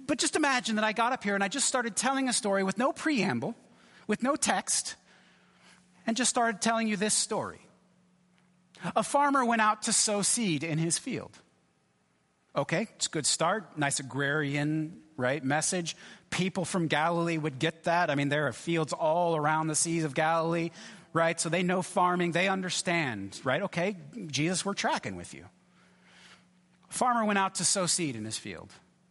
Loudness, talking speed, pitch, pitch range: -29 LUFS, 180 wpm, 180 Hz, 160-215 Hz